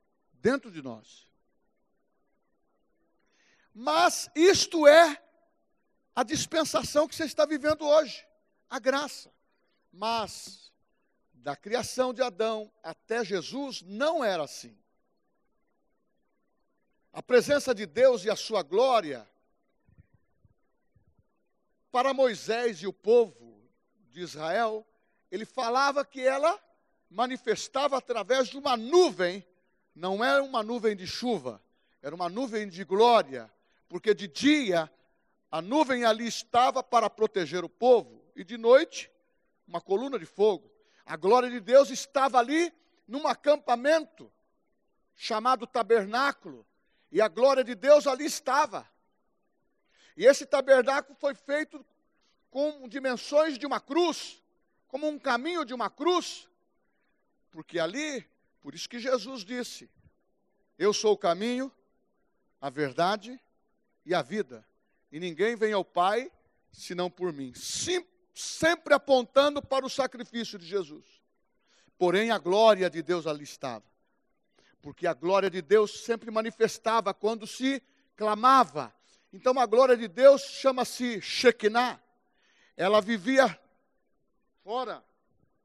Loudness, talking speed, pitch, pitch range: -27 LUFS, 120 wpm, 245 Hz, 205-280 Hz